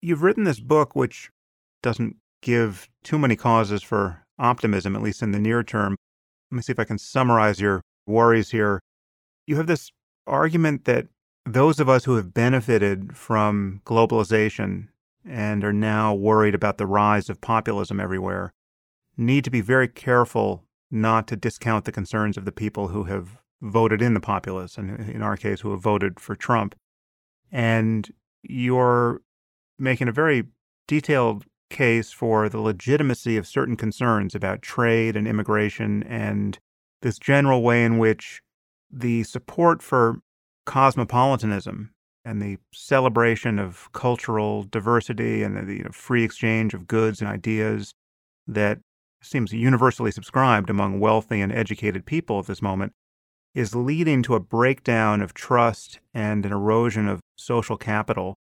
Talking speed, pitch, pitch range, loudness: 150 wpm, 110 Hz, 100-120 Hz, -23 LUFS